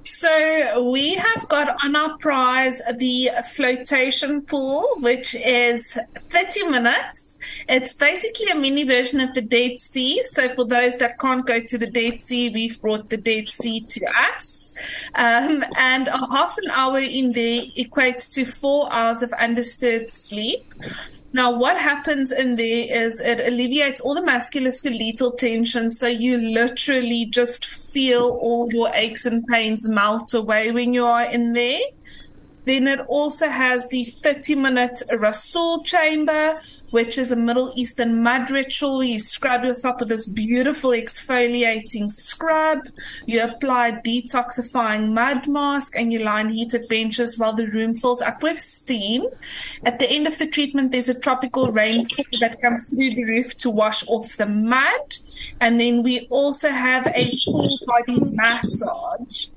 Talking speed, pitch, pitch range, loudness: 155 wpm, 245 Hz, 235-275 Hz, -19 LUFS